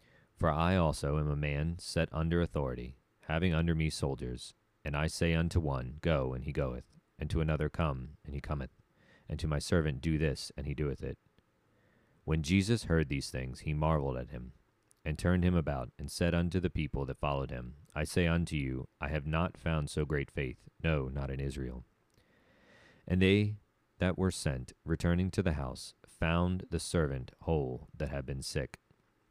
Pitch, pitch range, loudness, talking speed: 75 Hz, 70-85 Hz, -34 LUFS, 190 wpm